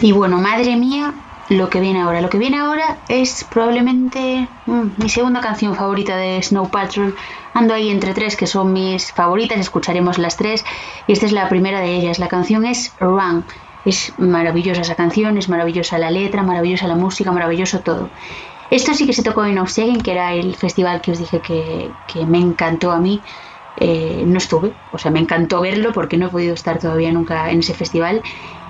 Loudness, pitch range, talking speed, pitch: -17 LUFS, 175-220 Hz, 200 wpm, 185 Hz